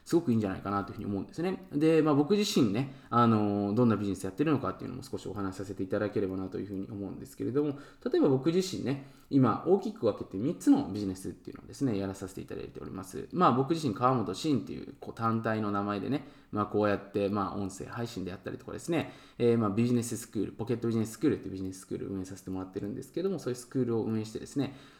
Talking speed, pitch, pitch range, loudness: 565 characters per minute, 115 Hz, 100-135 Hz, -31 LUFS